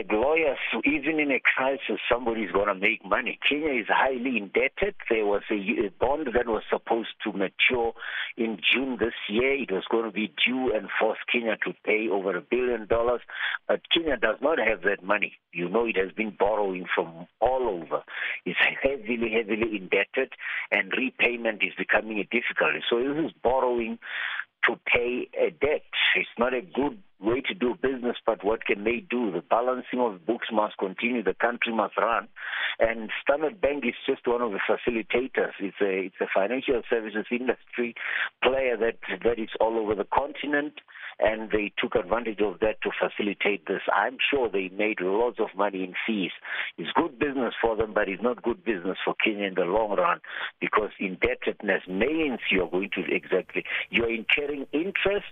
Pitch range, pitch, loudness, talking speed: 105-125 Hz, 115 Hz, -26 LUFS, 180 wpm